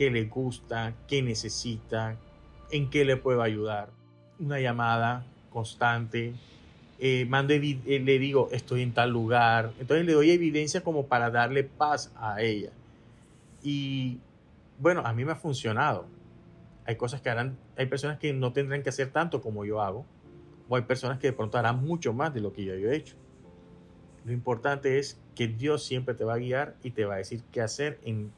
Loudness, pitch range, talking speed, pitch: -29 LUFS, 115-140 Hz, 185 wpm, 125 Hz